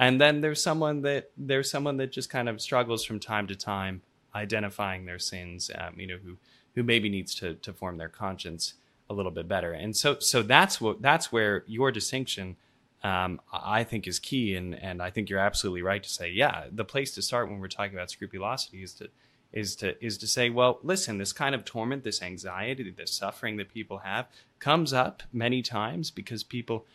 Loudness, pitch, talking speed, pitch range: -29 LUFS, 110 Hz, 210 wpm, 95-125 Hz